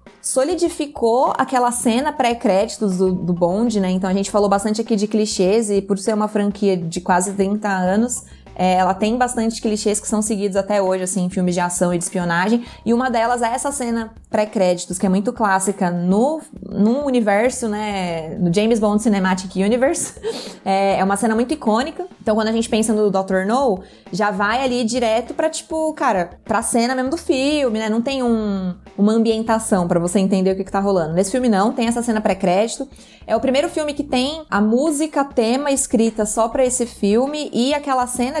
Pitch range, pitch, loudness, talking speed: 195-250 Hz, 220 Hz, -19 LUFS, 195 wpm